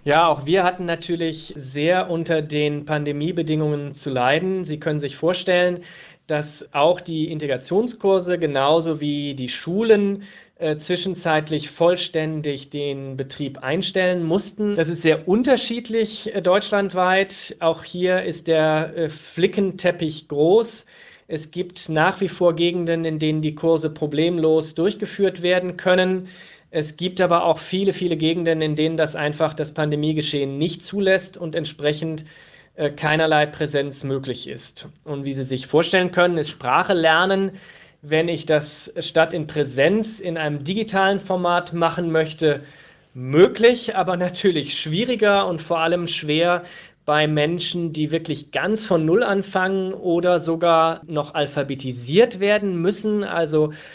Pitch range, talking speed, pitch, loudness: 155-185 Hz, 135 wpm, 165 Hz, -21 LUFS